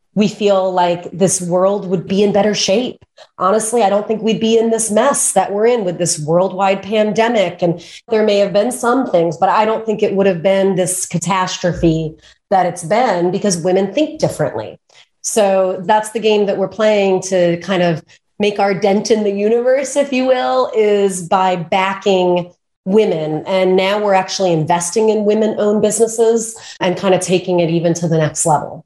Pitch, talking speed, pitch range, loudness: 195 Hz, 190 wpm, 180-215 Hz, -15 LUFS